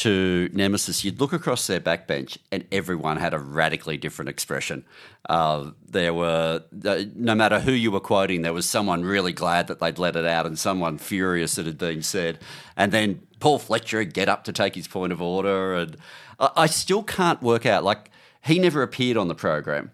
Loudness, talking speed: -23 LUFS, 200 wpm